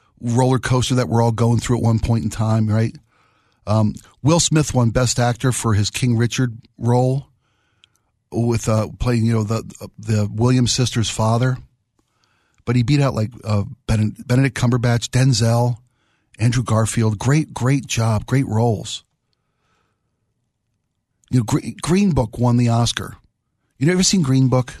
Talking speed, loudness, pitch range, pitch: 150 wpm, -19 LUFS, 110-125 Hz, 120 Hz